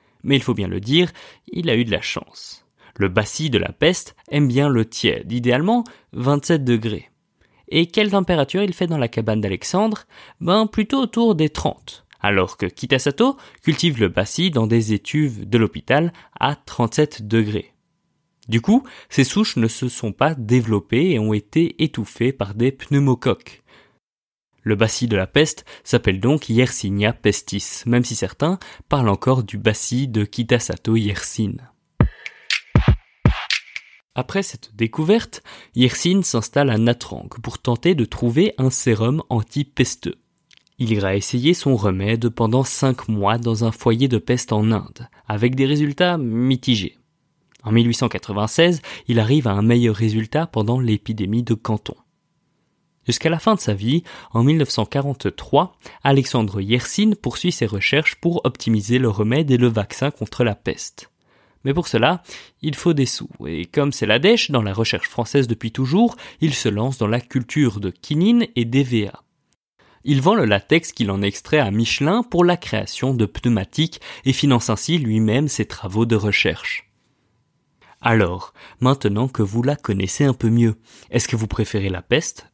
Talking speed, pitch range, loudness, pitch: 160 wpm, 110-150 Hz, -19 LUFS, 125 Hz